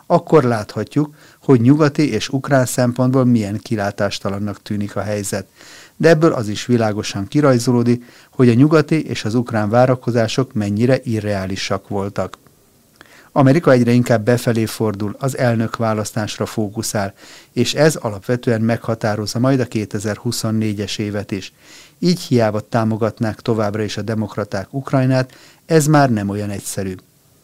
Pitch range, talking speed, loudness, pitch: 105-130 Hz, 130 wpm, -17 LUFS, 115 Hz